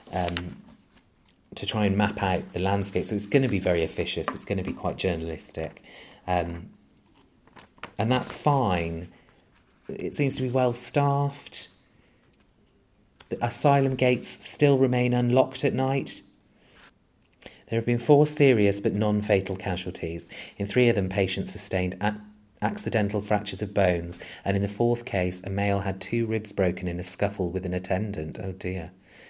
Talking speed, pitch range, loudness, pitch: 160 wpm, 90-120 Hz, -26 LUFS, 100 Hz